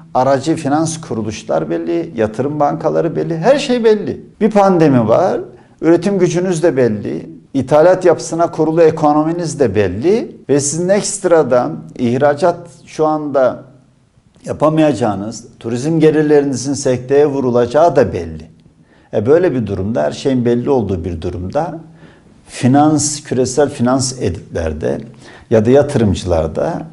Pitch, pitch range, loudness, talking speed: 145 Hz, 120-160 Hz, -14 LUFS, 120 wpm